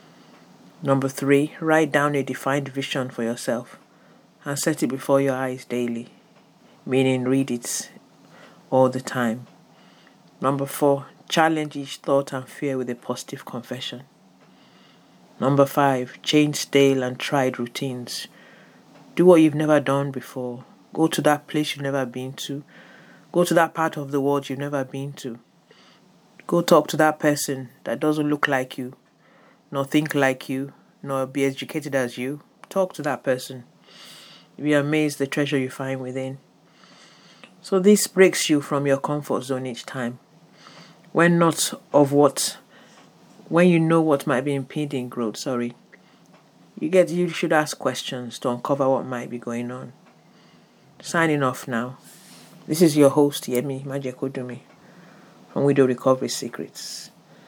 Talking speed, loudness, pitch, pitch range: 150 wpm, -22 LUFS, 140 Hz, 130-150 Hz